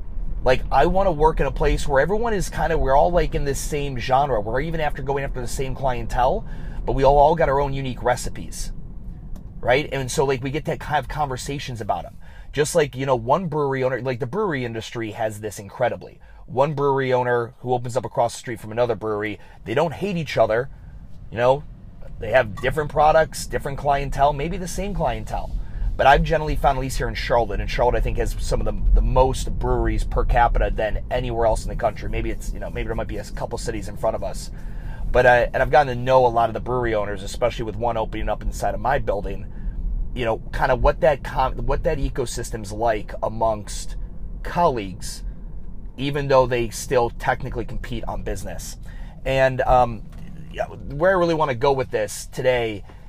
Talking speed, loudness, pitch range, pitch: 210 wpm, -22 LUFS, 110-140 Hz, 125 Hz